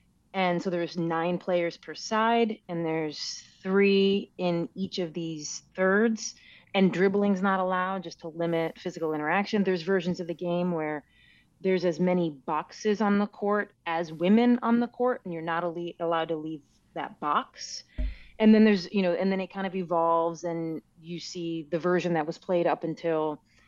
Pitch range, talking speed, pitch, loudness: 165-195 Hz, 185 wpm, 175 Hz, -28 LUFS